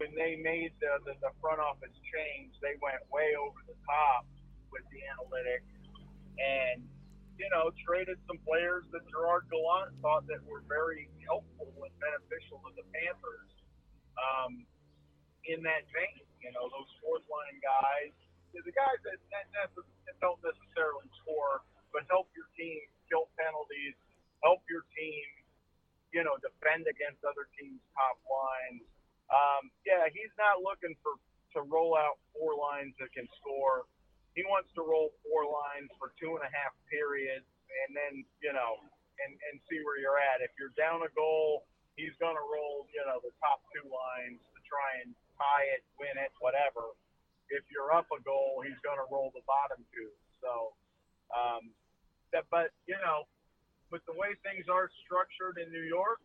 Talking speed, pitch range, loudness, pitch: 165 wpm, 135-175 Hz, -35 LUFS, 150 Hz